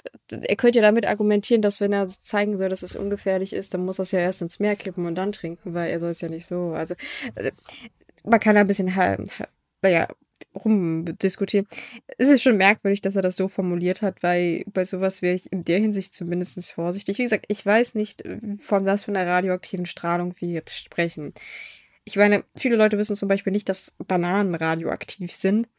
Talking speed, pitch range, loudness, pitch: 205 wpm, 180-205 Hz, -23 LUFS, 195 Hz